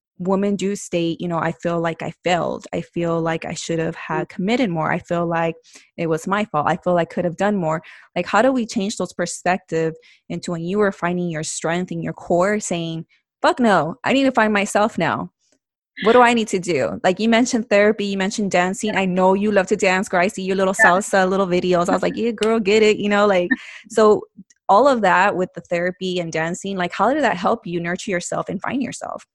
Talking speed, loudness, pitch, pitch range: 240 wpm, -19 LUFS, 185 Hz, 170-205 Hz